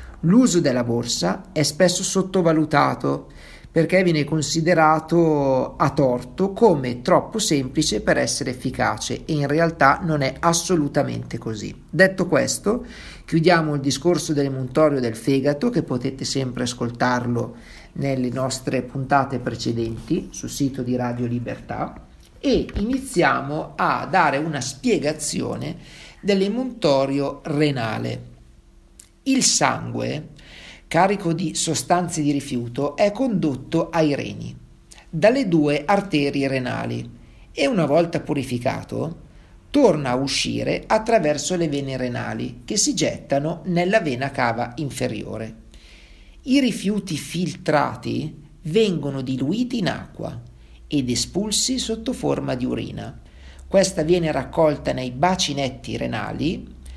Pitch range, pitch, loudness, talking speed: 125-170 Hz, 145 Hz, -21 LUFS, 110 wpm